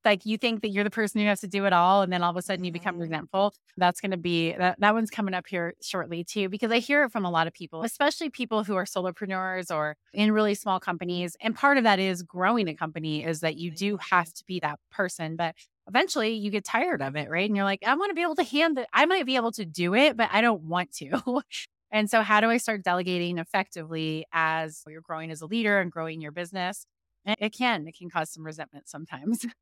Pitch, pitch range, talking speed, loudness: 190 Hz, 170-220 Hz, 260 wpm, -27 LUFS